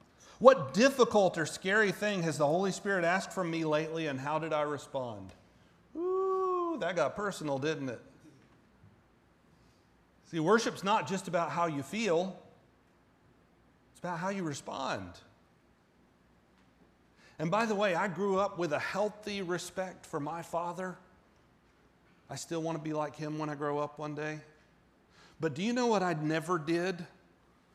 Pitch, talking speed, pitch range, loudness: 170 Hz, 155 wpm, 150-195 Hz, -32 LUFS